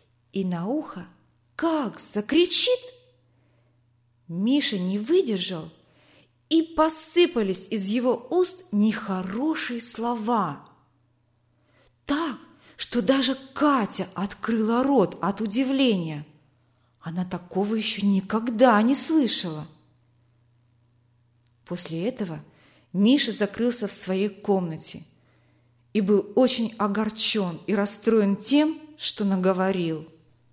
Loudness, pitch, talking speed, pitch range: -24 LUFS, 200 Hz, 90 wpm, 155-245 Hz